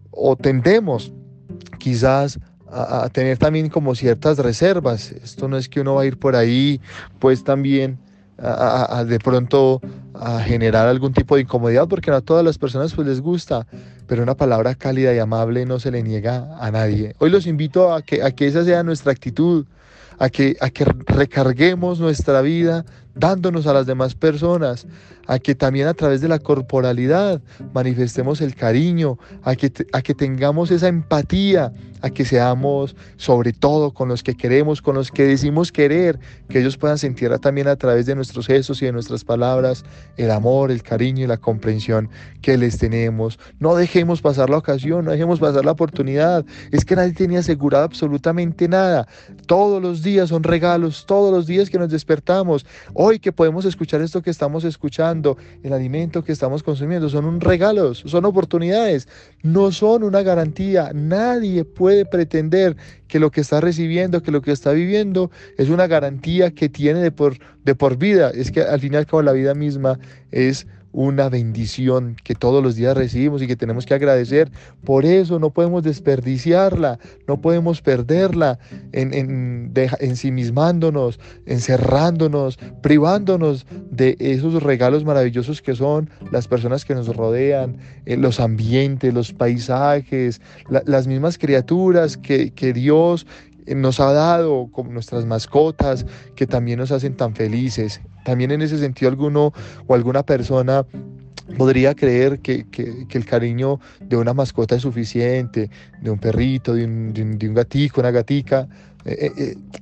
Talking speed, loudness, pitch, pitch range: 170 wpm, -18 LUFS, 140 Hz, 125-160 Hz